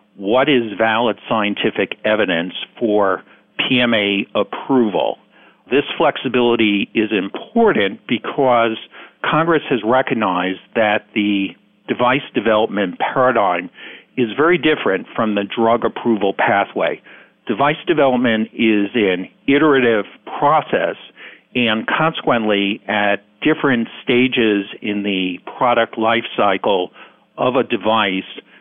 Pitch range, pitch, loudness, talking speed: 100-120 Hz, 115 Hz, -17 LUFS, 100 wpm